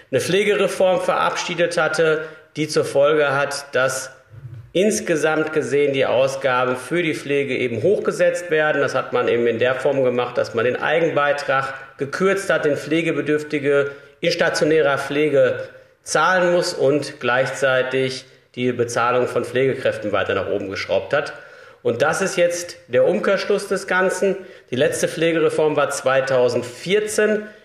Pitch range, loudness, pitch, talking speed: 140-195 Hz, -19 LUFS, 155 Hz, 140 wpm